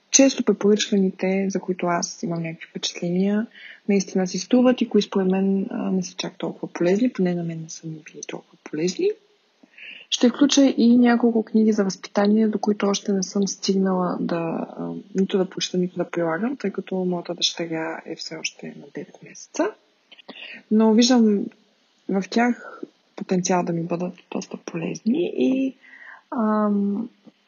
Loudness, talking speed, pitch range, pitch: -22 LUFS, 155 wpm, 180-230 Hz, 200 Hz